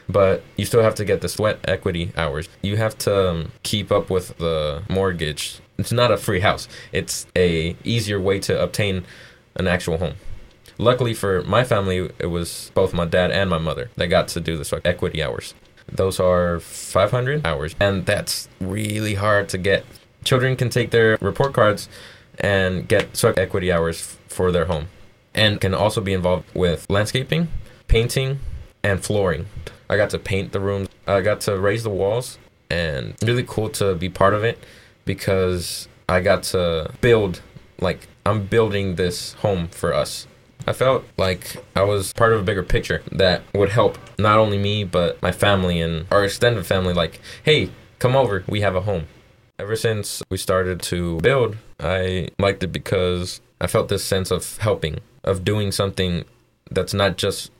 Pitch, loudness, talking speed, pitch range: 100 Hz, -21 LUFS, 180 wpm, 90-110 Hz